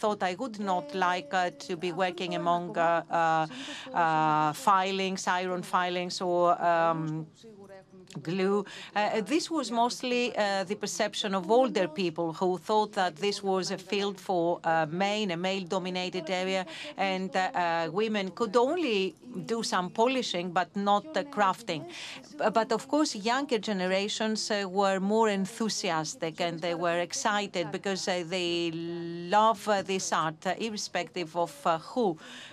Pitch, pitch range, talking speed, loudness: 190 Hz, 175-210 Hz, 150 wpm, -29 LUFS